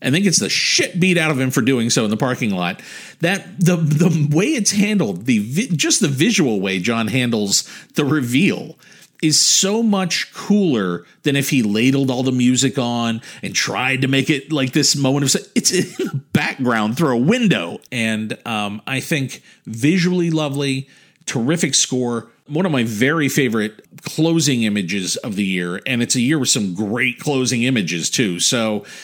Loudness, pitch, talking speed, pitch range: -17 LUFS, 135 Hz, 185 wpm, 120-170 Hz